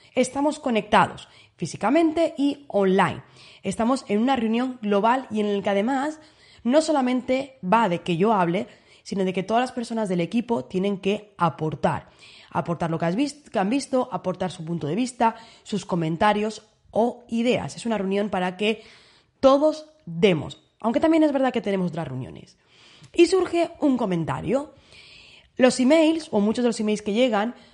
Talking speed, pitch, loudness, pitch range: 170 wpm, 220 Hz, -23 LUFS, 190-260 Hz